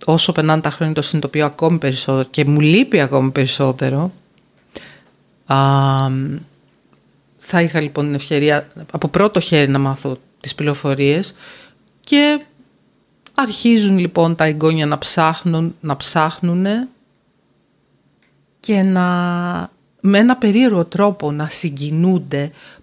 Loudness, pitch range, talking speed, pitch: -16 LUFS, 145-180 Hz, 115 wpm, 160 Hz